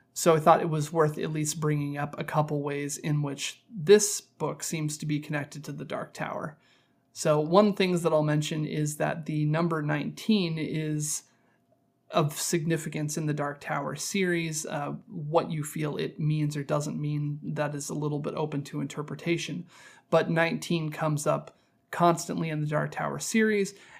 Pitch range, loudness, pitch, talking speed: 150-165 Hz, -28 LUFS, 155 Hz, 180 wpm